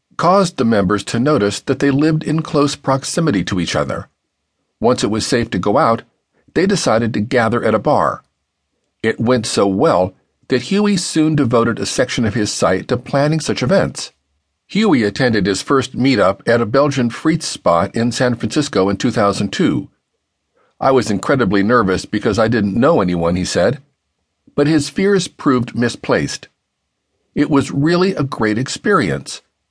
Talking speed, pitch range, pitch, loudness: 165 wpm, 105-145 Hz, 120 Hz, -16 LUFS